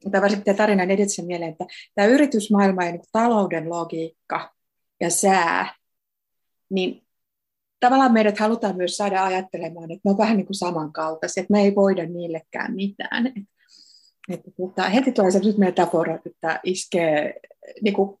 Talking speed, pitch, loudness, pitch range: 150 wpm, 195 Hz, -21 LUFS, 175-210 Hz